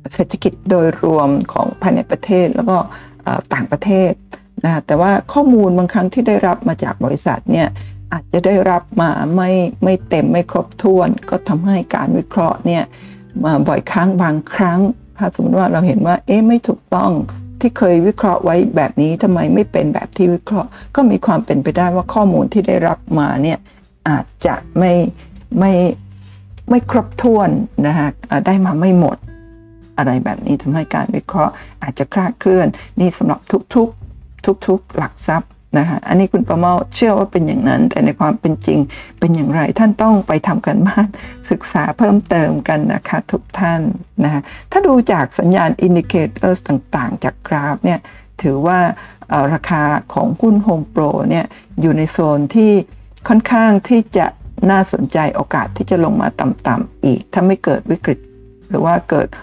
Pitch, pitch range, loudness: 185 Hz, 160-205 Hz, -15 LUFS